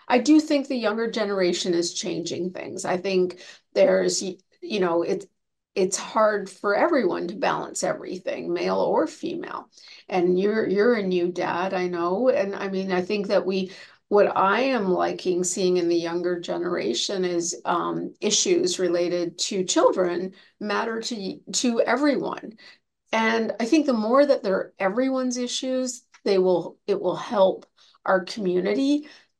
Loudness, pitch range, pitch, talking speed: -24 LUFS, 180-235 Hz, 195 Hz, 155 wpm